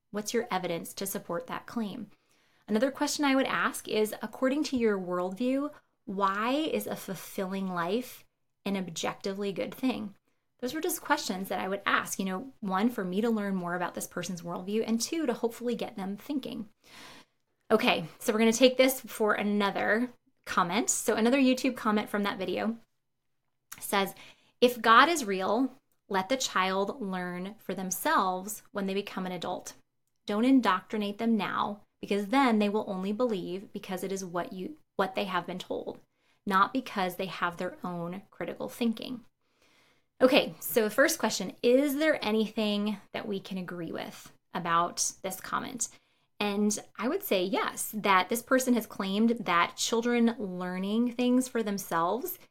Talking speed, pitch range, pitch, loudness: 165 wpm, 190-245 Hz, 210 Hz, -29 LUFS